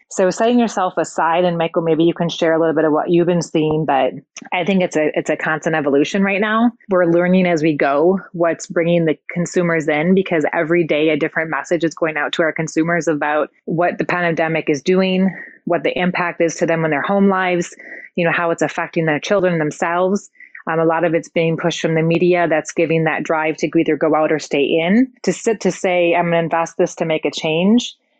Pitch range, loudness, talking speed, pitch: 160-180 Hz, -17 LUFS, 230 wpm, 170 Hz